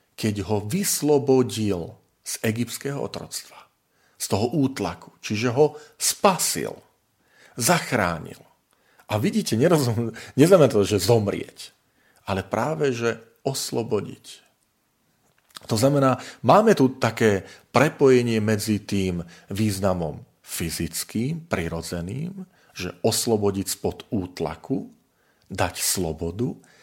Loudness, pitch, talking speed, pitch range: -23 LUFS, 115 Hz, 90 wpm, 100-135 Hz